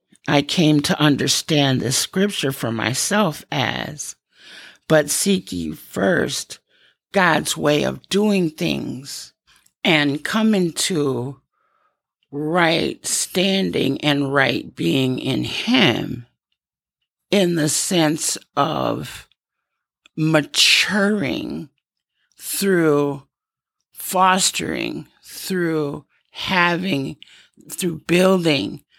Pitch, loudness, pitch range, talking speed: 155 Hz, -19 LUFS, 140-185 Hz, 80 wpm